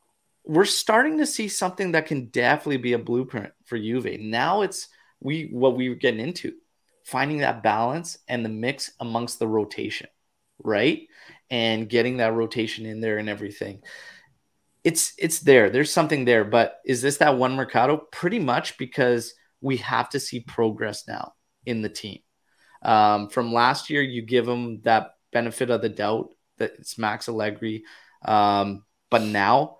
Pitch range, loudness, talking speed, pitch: 110-135 Hz, -23 LUFS, 165 wpm, 120 Hz